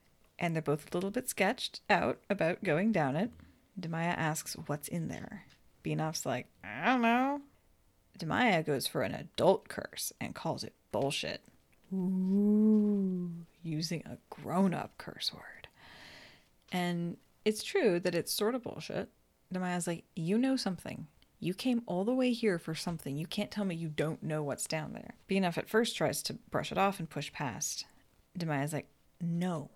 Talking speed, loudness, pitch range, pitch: 170 wpm, -34 LUFS, 160-210 Hz, 180 Hz